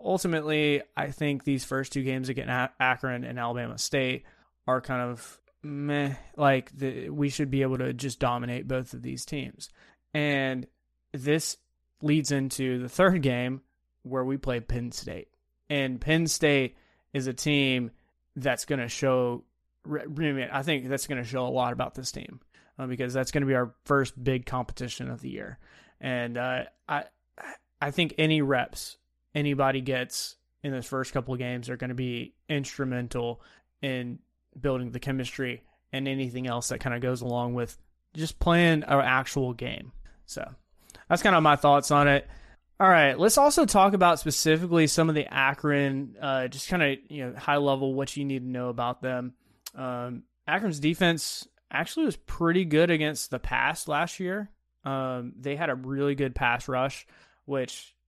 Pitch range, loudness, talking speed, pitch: 125-145 Hz, -27 LUFS, 175 wpm, 135 Hz